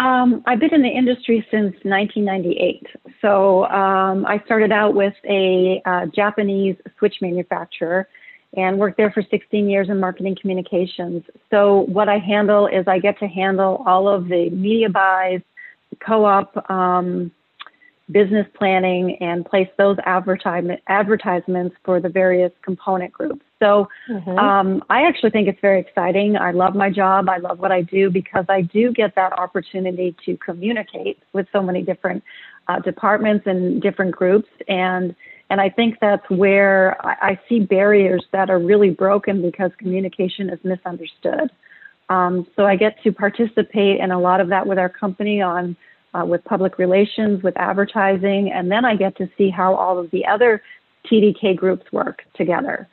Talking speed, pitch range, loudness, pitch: 165 wpm, 185-210 Hz, -18 LUFS, 195 Hz